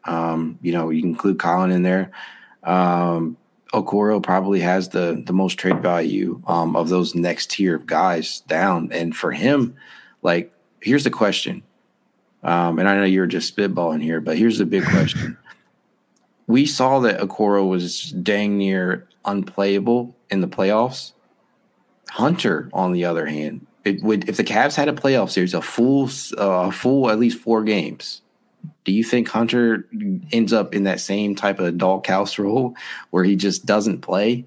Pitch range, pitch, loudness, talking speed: 90-115 Hz, 100 Hz, -20 LUFS, 170 wpm